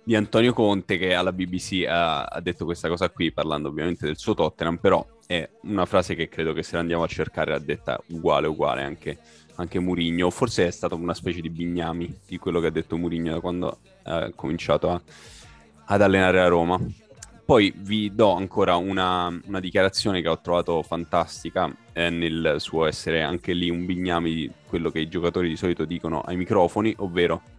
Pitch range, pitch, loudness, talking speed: 85-95 Hz, 85 Hz, -24 LUFS, 190 wpm